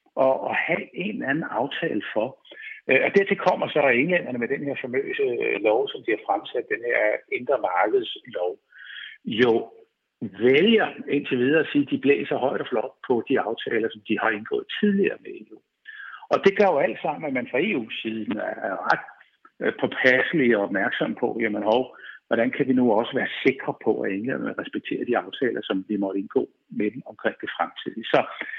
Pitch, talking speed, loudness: 290 Hz, 190 wpm, -24 LUFS